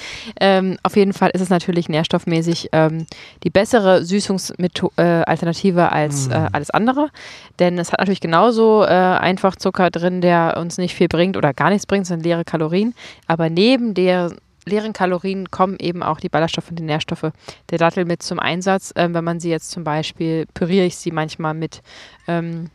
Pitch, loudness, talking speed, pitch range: 175 Hz, -18 LUFS, 185 wpm, 165-190 Hz